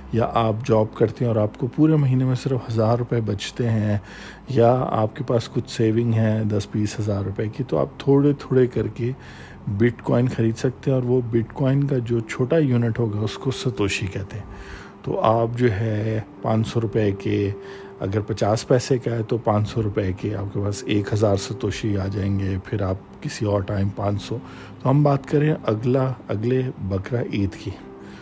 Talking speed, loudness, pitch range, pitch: 205 wpm, -22 LUFS, 105-125 Hz, 110 Hz